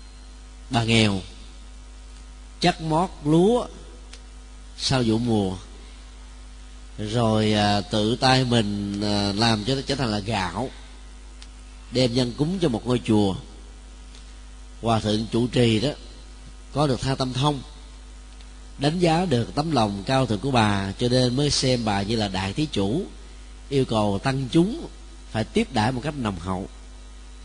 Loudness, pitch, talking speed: -23 LUFS, 105 Hz, 150 wpm